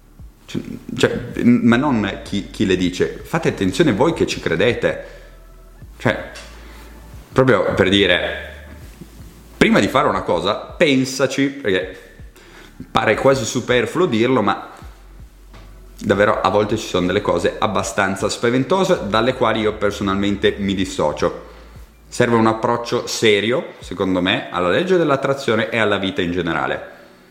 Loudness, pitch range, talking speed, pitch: -18 LUFS, 95-120 Hz, 125 wpm, 105 Hz